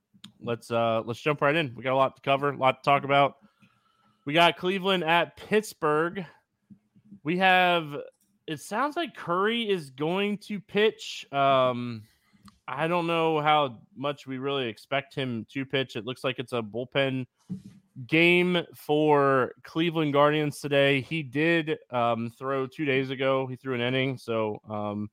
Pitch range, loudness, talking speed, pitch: 130-170 Hz, -26 LUFS, 160 wpm, 140 Hz